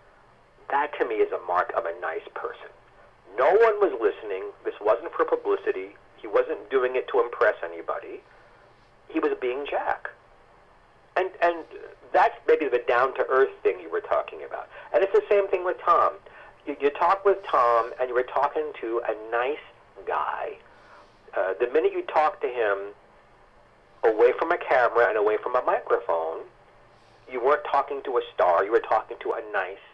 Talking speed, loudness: 175 wpm, -25 LUFS